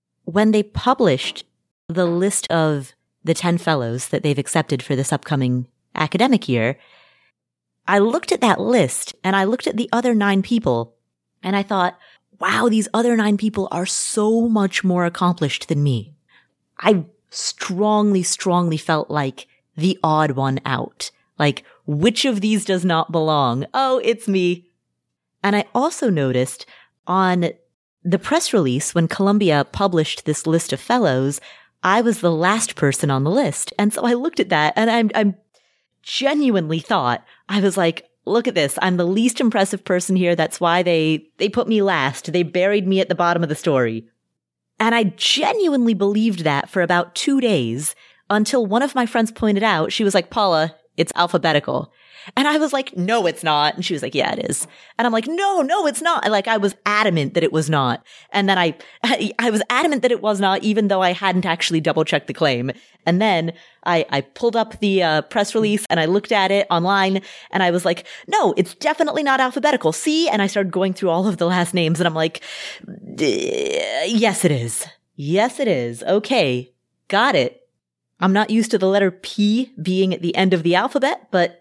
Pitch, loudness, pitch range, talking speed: 185 Hz, -19 LUFS, 160-220 Hz, 190 wpm